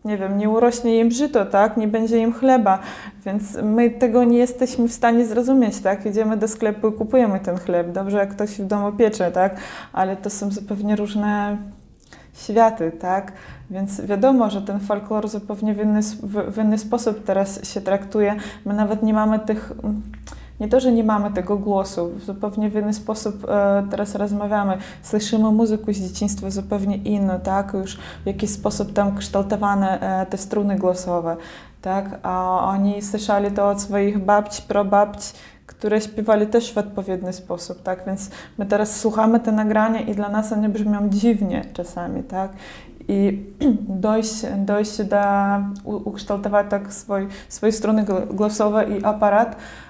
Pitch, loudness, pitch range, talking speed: 205 Hz, -21 LUFS, 200-215 Hz, 160 wpm